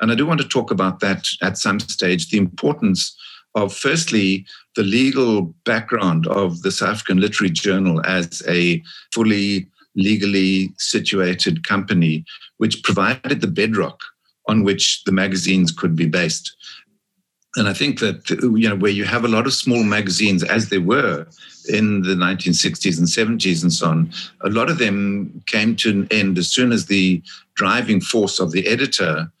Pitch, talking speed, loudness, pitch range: 100 Hz, 170 wpm, -18 LUFS, 90-110 Hz